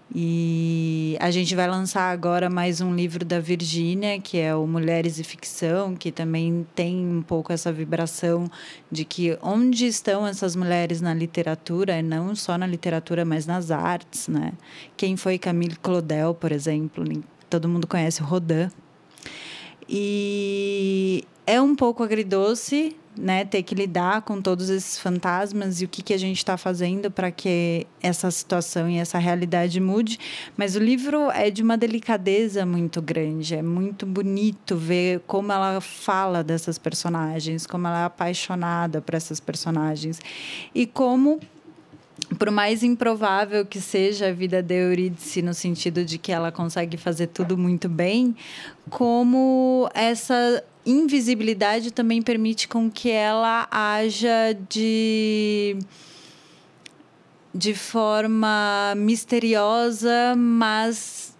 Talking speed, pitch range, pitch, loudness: 135 wpm, 170-215 Hz, 185 Hz, -23 LUFS